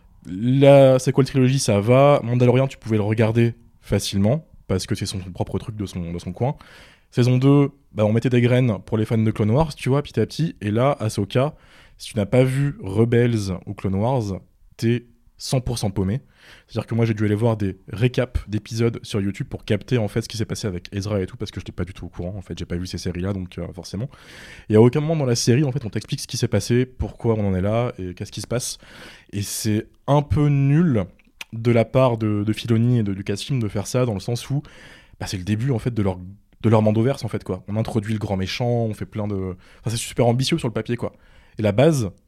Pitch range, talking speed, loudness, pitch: 100-125 Hz, 265 wpm, -21 LUFS, 110 Hz